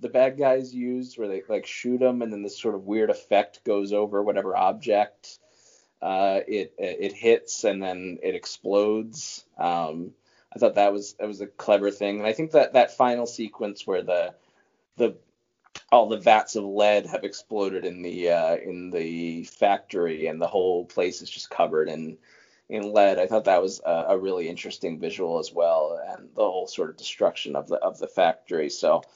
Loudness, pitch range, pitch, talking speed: -25 LUFS, 100-125 Hz, 105 Hz, 195 wpm